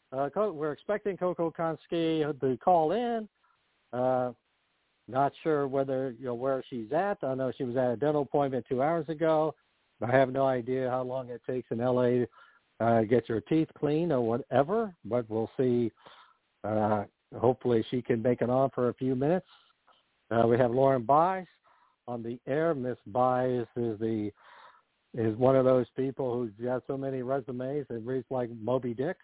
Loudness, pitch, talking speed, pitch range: -29 LUFS, 130 Hz, 180 wpm, 120-145 Hz